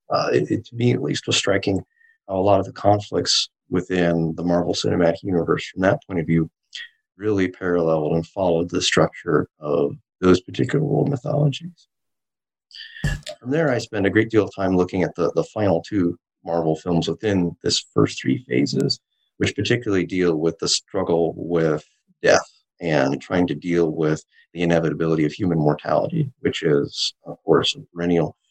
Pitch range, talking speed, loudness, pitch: 85-105 Hz, 175 wpm, -21 LUFS, 90 Hz